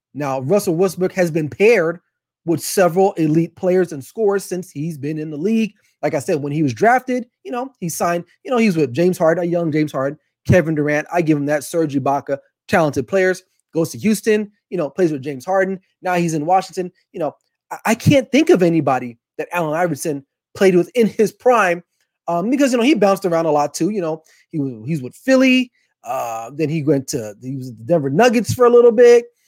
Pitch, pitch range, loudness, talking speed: 175 Hz, 150-200 Hz, -18 LUFS, 220 wpm